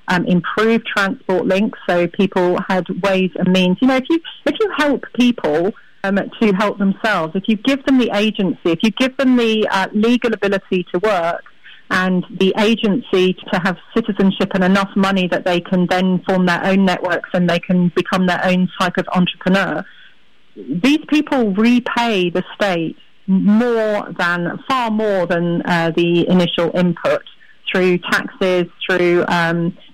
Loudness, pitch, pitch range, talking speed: -16 LUFS, 190 Hz, 180-220 Hz, 165 wpm